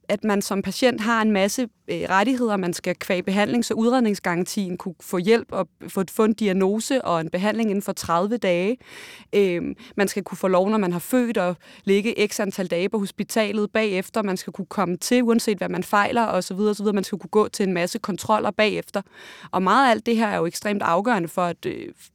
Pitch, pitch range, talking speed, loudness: 205 Hz, 185-220 Hz, 230 wpm, -22 LUFS